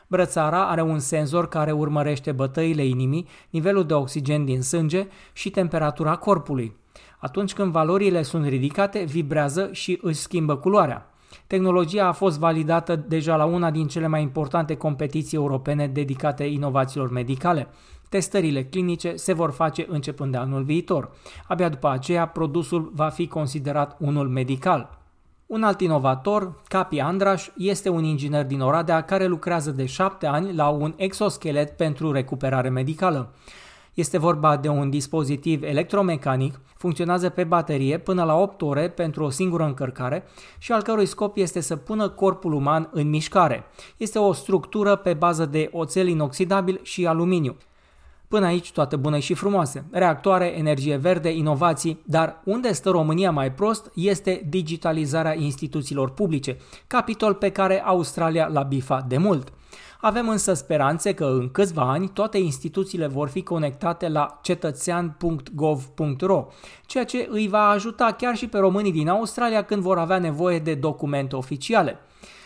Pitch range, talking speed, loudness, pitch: 150-185 Hz, 150 wpm, -23 LUFS, 165 Hz